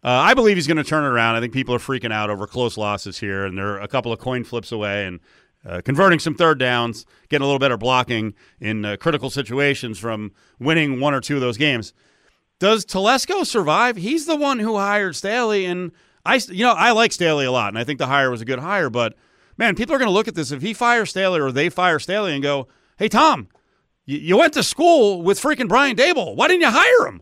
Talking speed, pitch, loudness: 245 wpm, 145 Hz, -19 LUFS